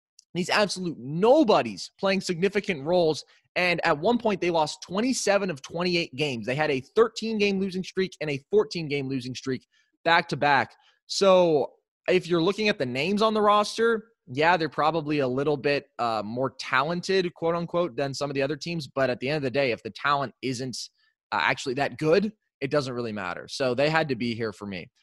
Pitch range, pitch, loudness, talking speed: 140-195 Hz, 165 Hz, -25 LUFS, 205 wpm